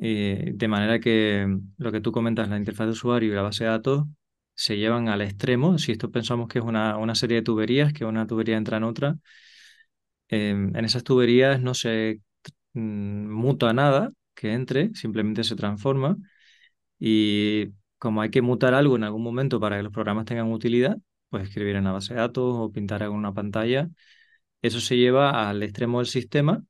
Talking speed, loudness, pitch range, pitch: 190 wpm, -24 LUFS, 110-130 Hz, 115 Hz